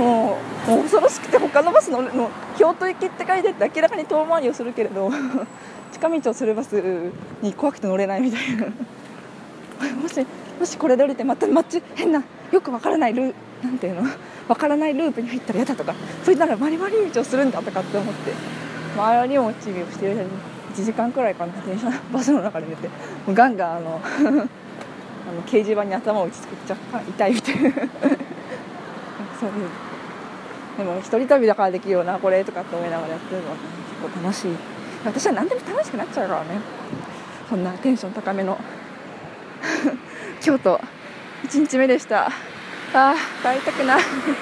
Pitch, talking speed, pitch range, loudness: 245 Hz, 340 characters per minute, 200-285 Hz, -22 LUFS